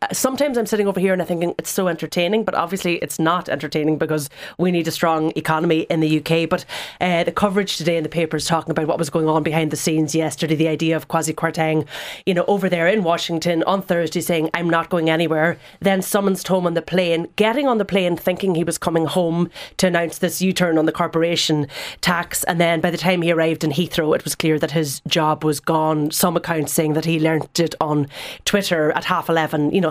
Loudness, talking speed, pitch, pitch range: -19 LUFS, 235 wpm, 165 Hz, 160-180 Hz